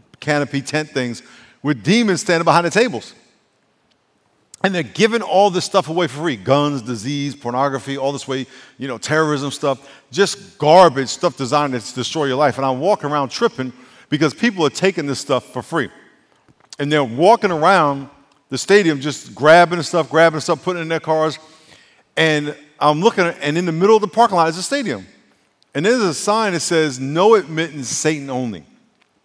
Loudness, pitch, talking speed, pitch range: -17 LUFS, 155 Hz, 190 wpm, 140-180 Hz